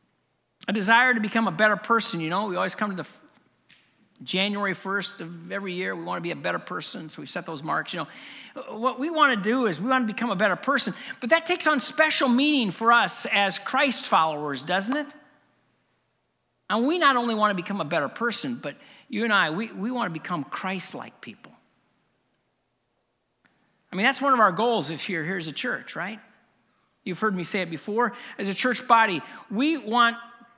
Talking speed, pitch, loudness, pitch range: 210 wpm, 225 Hz, -24 LUFS, 195-250 Hz